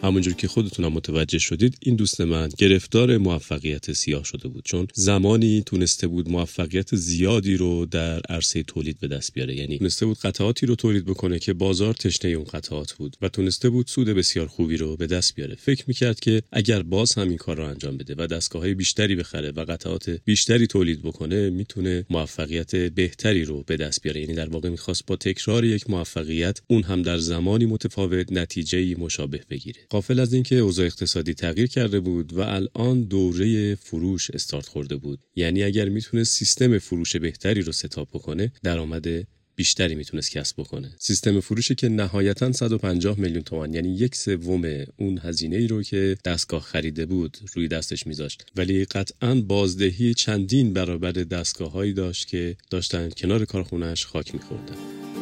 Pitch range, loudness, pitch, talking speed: 85-105 Hz, -23 LUFS, 95 Hz, 170 wpm